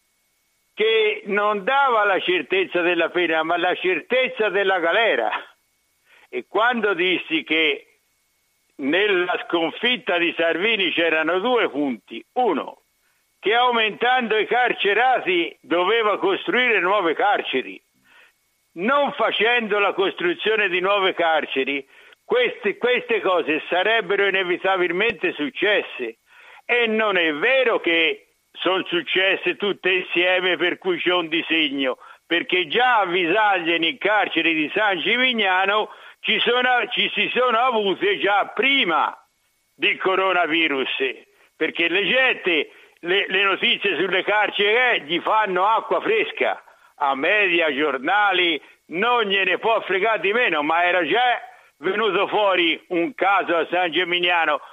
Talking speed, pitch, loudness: 115 wpm, 250 Hz, -20 LUFS